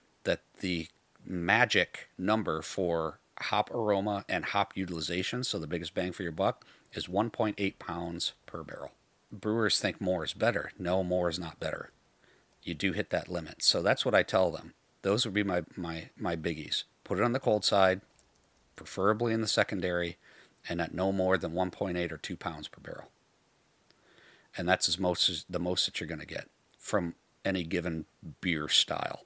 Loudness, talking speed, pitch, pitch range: -31 LUFS, 185 wpm, 95 Hz, 85-100 Hz